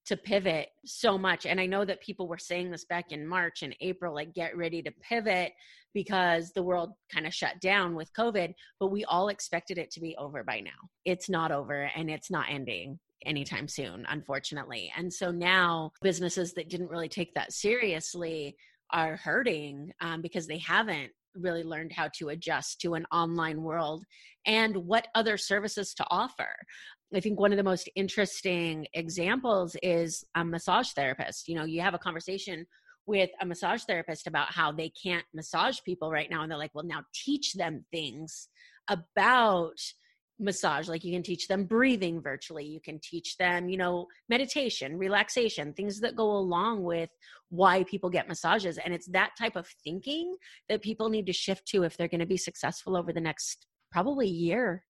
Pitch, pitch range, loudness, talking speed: 175 Hz, 160-195 Hz, -31 LUFS, 185 wpm